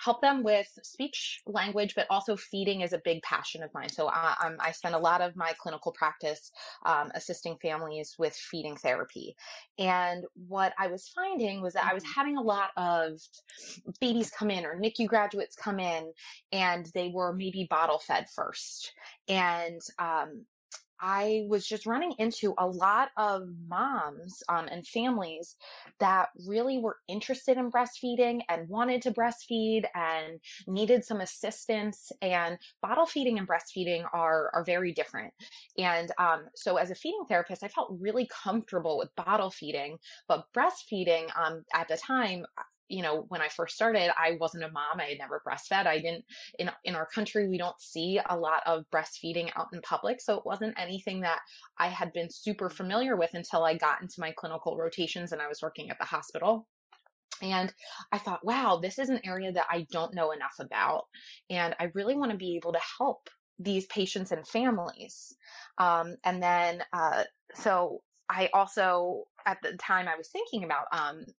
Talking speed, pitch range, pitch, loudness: 180 wpm, 170-220 Hz, 185 Hz, -31 LUFS